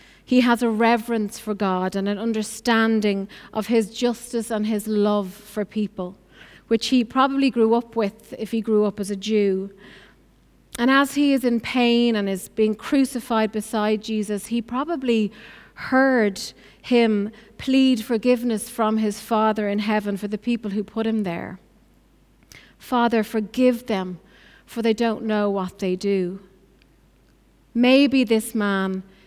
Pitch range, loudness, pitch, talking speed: 205-235 Hz, -22 LUFS, 220 Hz, 150 wpm